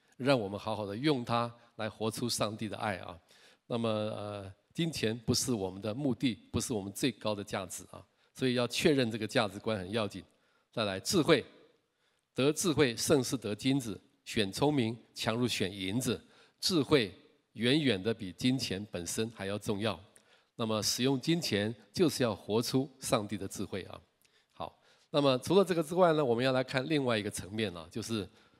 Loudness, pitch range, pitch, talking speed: -32 LUFS, 105-130 Hz, 115 Hz, 265 characters per minute